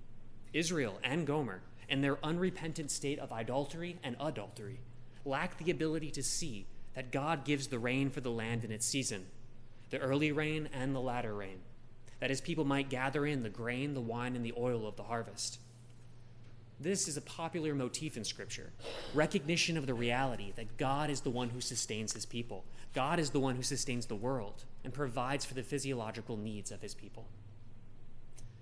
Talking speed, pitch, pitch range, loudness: 180 wpm, 125 Hz, 115-145 Hz, -37 LUFS